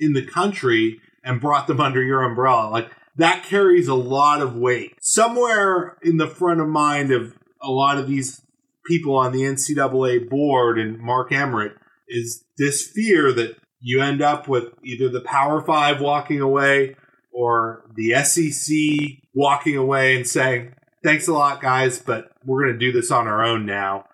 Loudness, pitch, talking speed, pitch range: -19 LUFS, 135 Hz, 175 wpm, 125-150 Hz